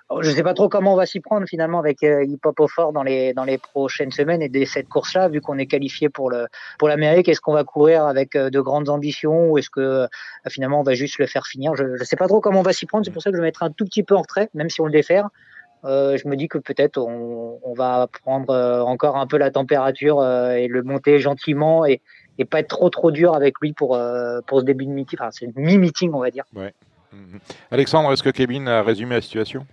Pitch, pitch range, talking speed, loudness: 140 Hz, 130-160 Hz, 260 wpm, -19 LUFS